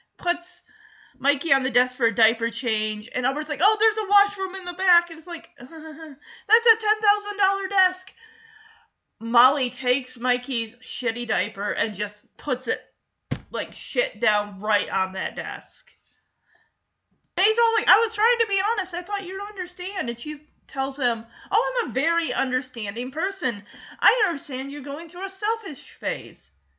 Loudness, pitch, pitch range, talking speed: -24 LUFS, 310 Hz, 245-405 Hz, 170 wpm